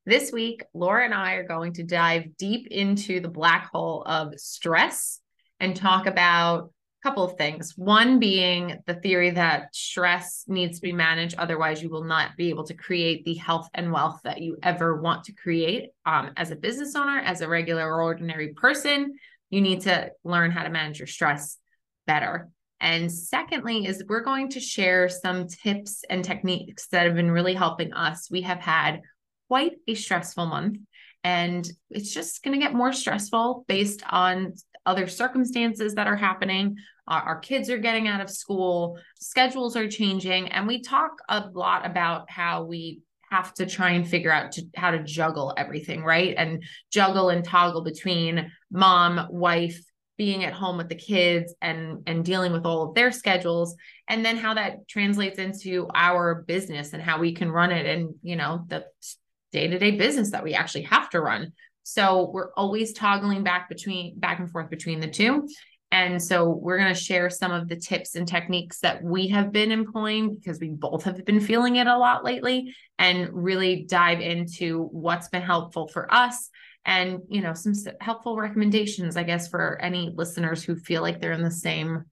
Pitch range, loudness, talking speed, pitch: 170-205 Hz, -24 LUFS, 185 wpm, 180 Hz